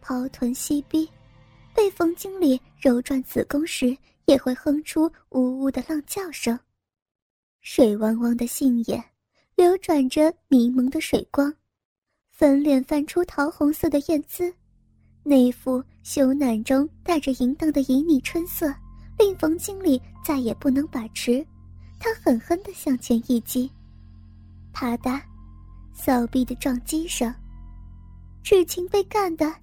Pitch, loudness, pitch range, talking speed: 275 Hz, -23 LUFS, 250-320 Hz, 190 characters per minute